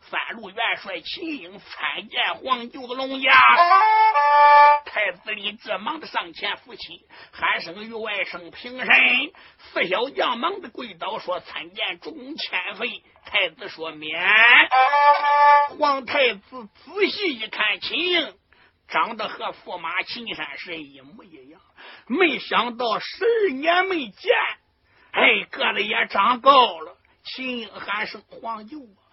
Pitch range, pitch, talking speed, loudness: 220-305 Hz, 265 Hz, 185 characters per minute, -20 LUFS